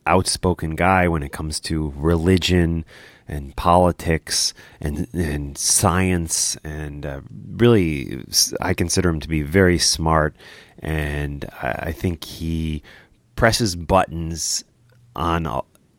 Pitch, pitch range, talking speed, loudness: 85 Hz, 75-90 Hz, 115 wpm, -20 LUFS